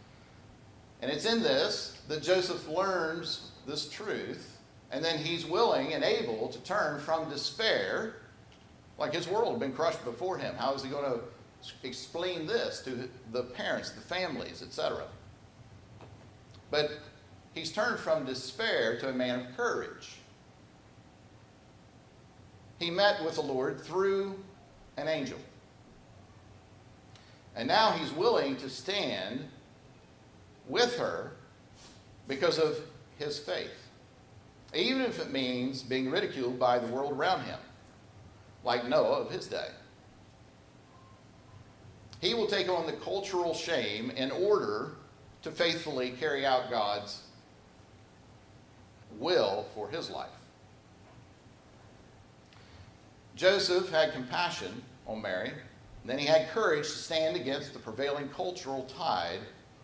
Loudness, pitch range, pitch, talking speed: -32 LUFS, 115-160 Hz, 135 Hz, 120 wpm